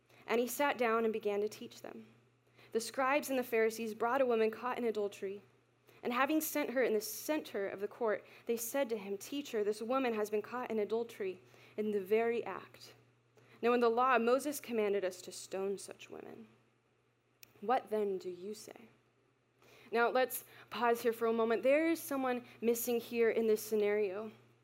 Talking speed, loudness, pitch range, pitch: 190 wpm, -35 LUFS, 210-250 Hz, 225 Hz